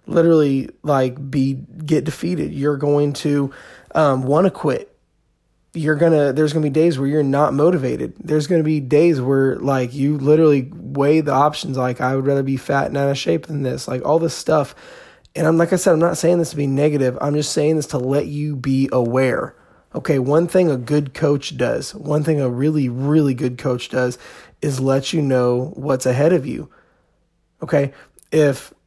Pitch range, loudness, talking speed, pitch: 135-155 Hz, -18 LUFS, 205 wpm, 145 Hz